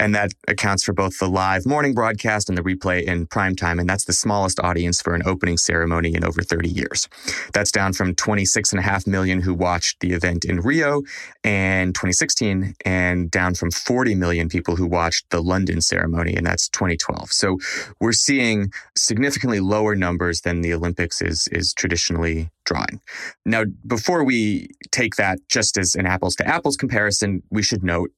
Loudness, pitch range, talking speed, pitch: -20 LUFS, 85-105 Hz, 190 wpm, 95 Hz